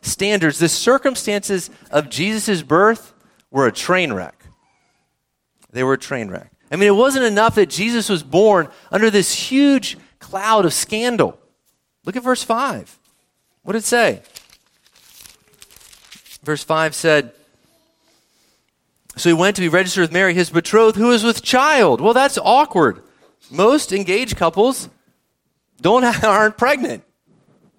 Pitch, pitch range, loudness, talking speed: 205 Hz, 170-230 Hz, -16 LUFS, 140 wpm